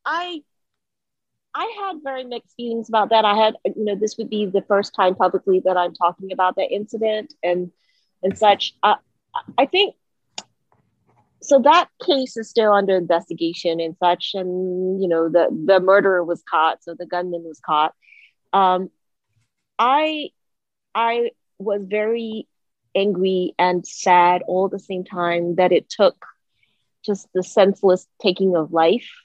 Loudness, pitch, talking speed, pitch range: -20 LUFS, 190 Hz, 155 wpm, 180-220 Hz